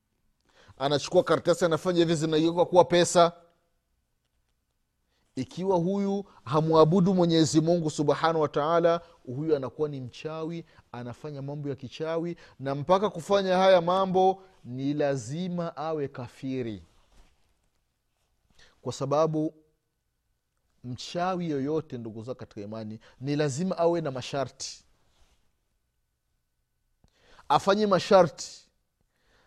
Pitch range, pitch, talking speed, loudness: 125-170 Hz, 155 Hz, 95 wpm, -26 LUFS